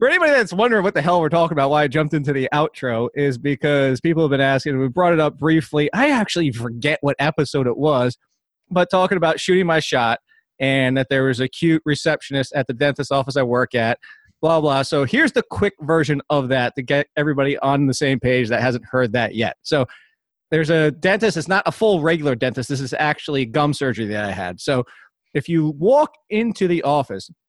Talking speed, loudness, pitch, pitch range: 220 wpm, -19 LUFS, 145 Hz, 135-165 Hz